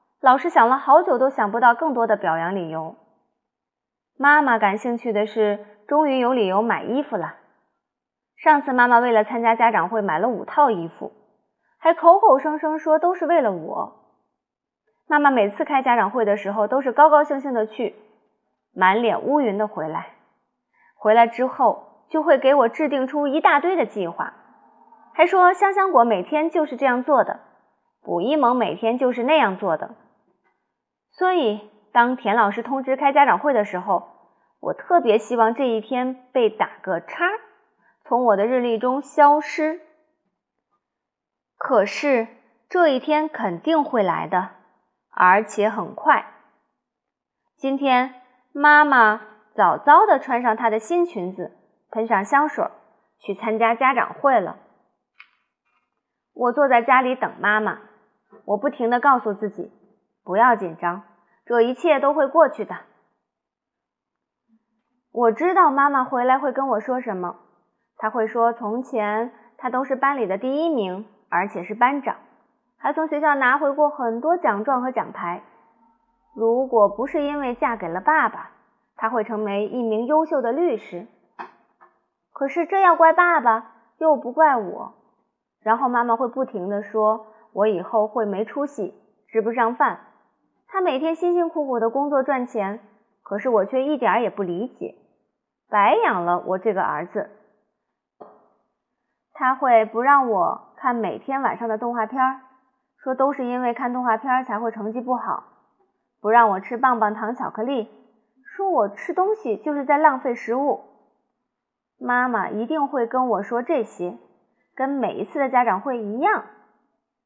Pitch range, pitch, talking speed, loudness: 215-285 Hz, 245 Hz, 220 characters per minute, -20 LUFS